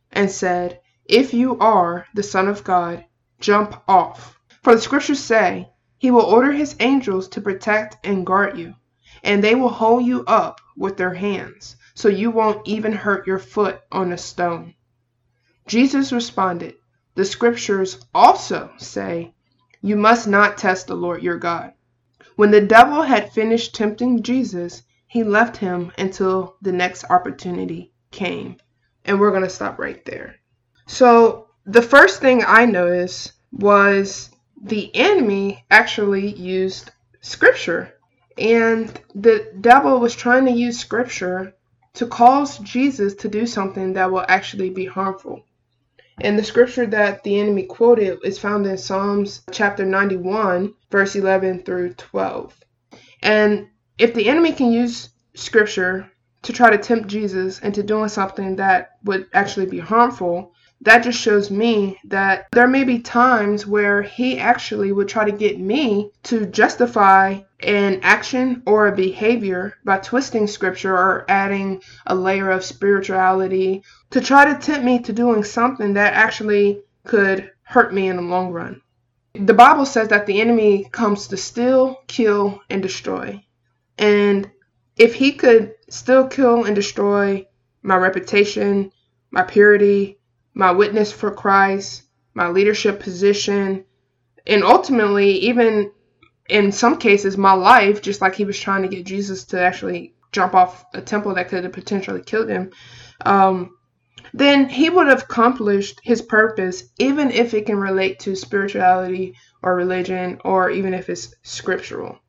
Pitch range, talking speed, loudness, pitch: 185-225 Hz, 150 wpm, -17 LUFS, 200 Hz